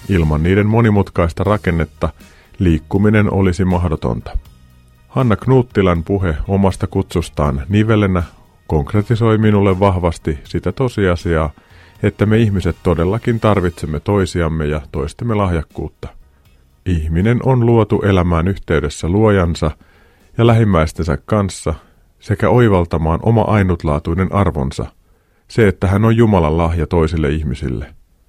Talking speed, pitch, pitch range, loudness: 105 wpm, 90 Hz, 80-105 Hz, -16 LUFS